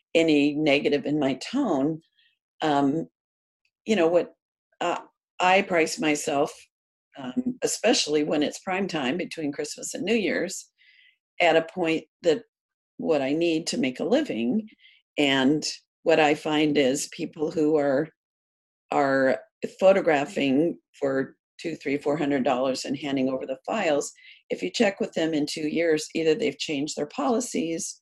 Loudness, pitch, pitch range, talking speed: -25 LUFS, 155 Hz, 145-190 Hz, 150 wpm